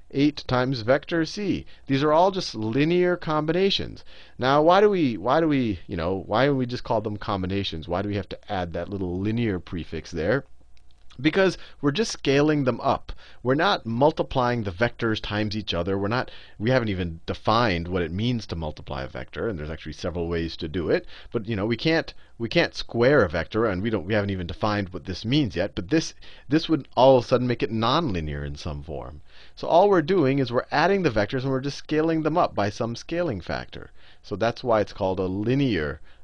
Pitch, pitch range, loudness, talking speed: 110 Hz, 90-135 Hz, -24 LUFS, 230 wpm